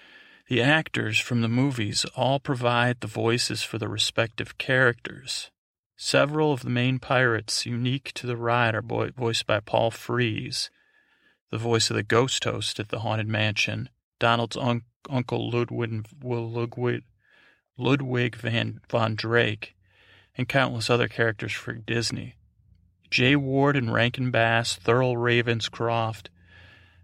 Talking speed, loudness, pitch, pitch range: 130 wpm, -25 LUFS, 115 Hz, 110-125 Hz